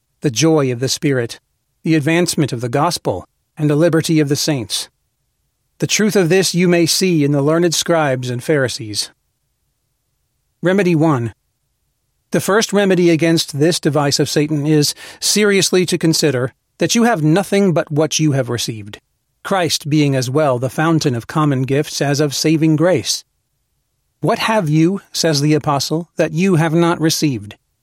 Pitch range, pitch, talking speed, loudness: 145-175 Hz, 155 Hz, 165 wpm, -15 LUFS